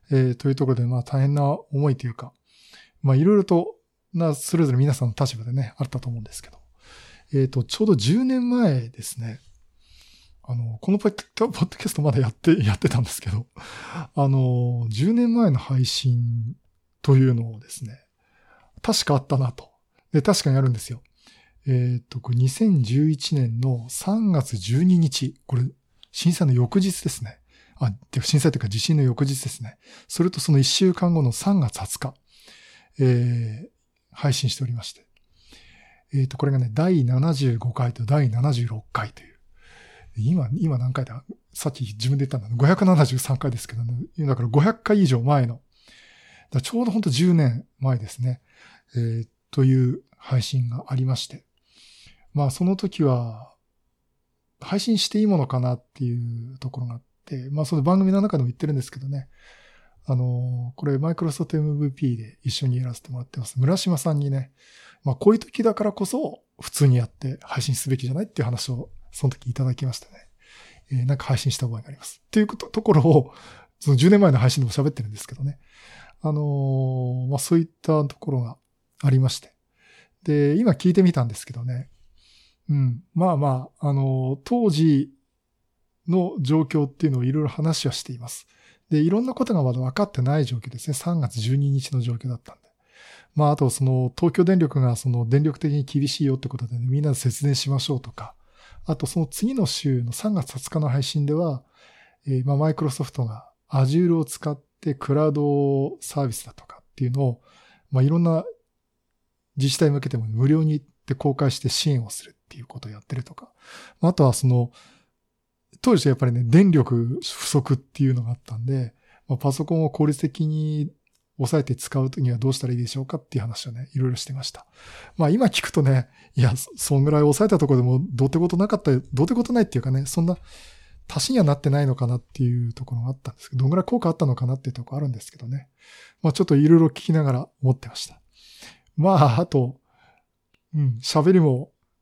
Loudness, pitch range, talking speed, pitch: -22 LUFS, 125-155 Hz, 360 characters per minute, 135 Hz